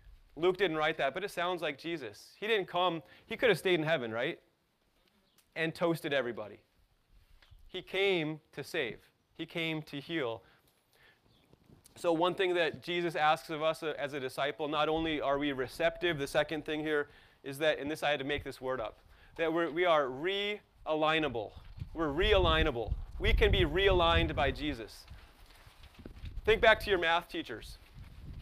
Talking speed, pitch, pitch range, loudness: 170 wpm, 160 Hz, 145-175 Hz, -32 LUFS